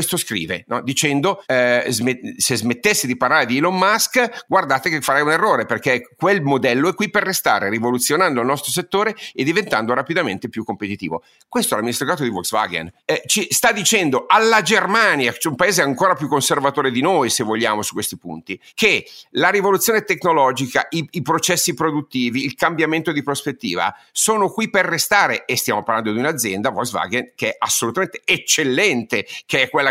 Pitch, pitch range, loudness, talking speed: 150 Hz, 125-190 Hz, -18 LUFS, 180 wpm